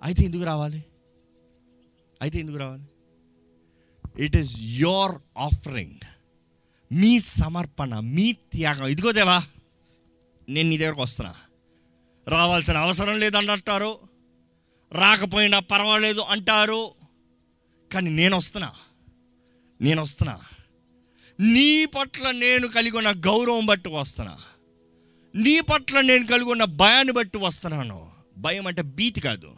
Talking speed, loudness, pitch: 100 wpm, -20 LUFS, 150 Hz